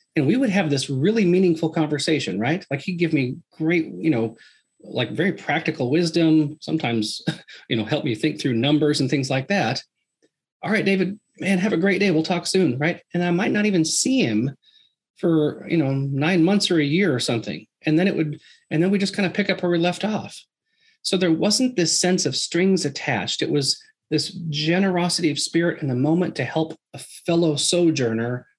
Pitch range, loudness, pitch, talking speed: 145-180 Hz, -21 LUFS, 160 Hz, 210 wpm